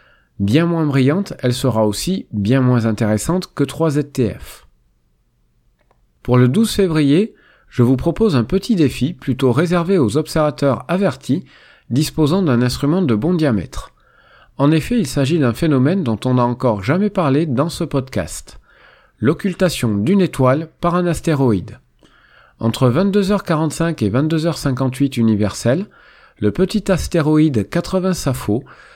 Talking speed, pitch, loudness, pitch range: 130 wpm, 145 Hz, -17 LUFS, 125-170 Hz